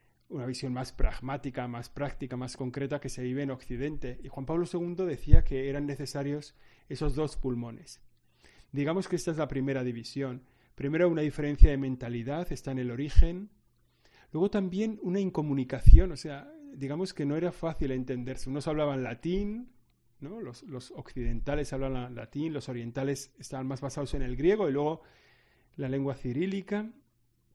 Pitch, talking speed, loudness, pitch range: 140 Hz, 165 wpm, -32 LUFS, 130-155 Hz